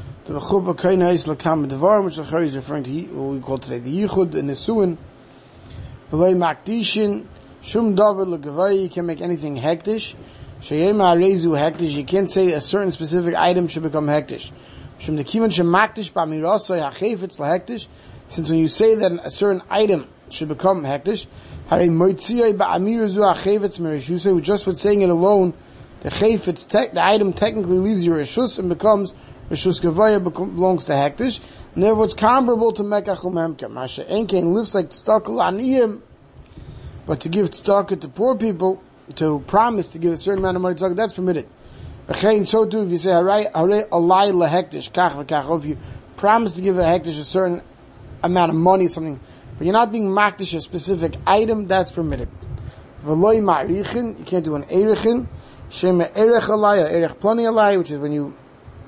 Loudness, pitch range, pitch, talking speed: -19 LUFS, 160-205 Hz, 180 Hz, 145 wpm